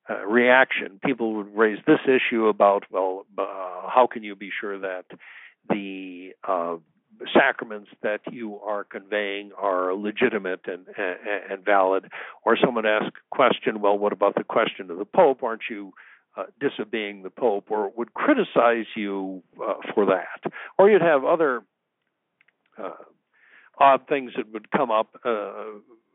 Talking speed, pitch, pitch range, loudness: 160 wpm, 105 Hz, 95-115 Hz, -23 LUFS